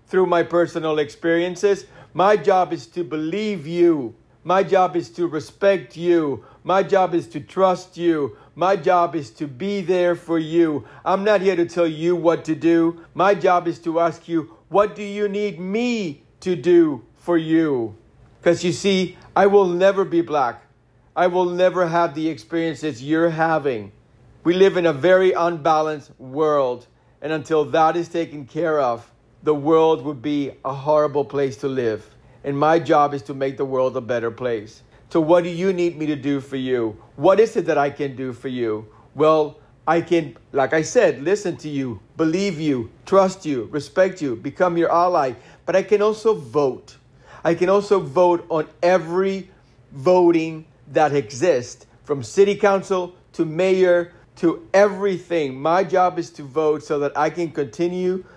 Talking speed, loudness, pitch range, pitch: 175 wpm, -20 LUFS, 140-180 Hz, 165 Hz